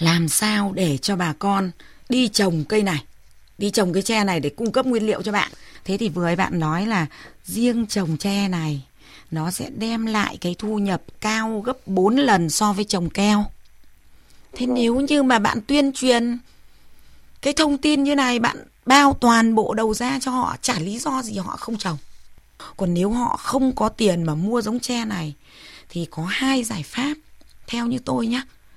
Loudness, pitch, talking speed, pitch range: -21 LUFS, 215 Hz, 200 wpm, 180-245 Hz